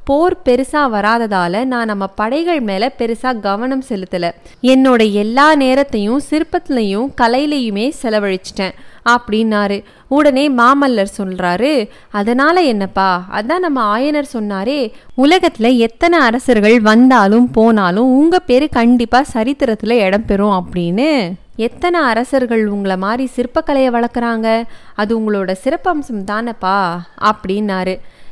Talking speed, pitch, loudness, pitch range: 105 wpm, 235 Hz, -14 LUFS, 205-270 Hz